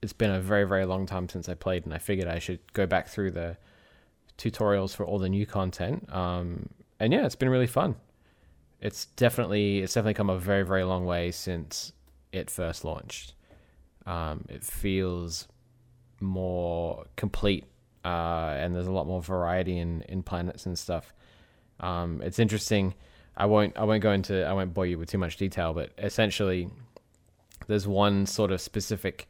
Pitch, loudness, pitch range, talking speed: 95 Hz, -29 LUFS, 85-105 Hz, 180 wpm